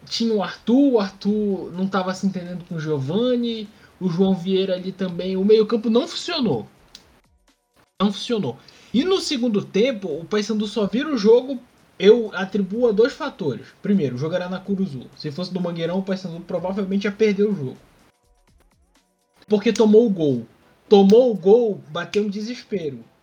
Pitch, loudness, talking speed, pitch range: 205 Hz, -21 LUFS, 170 wpm, 185-225 Hz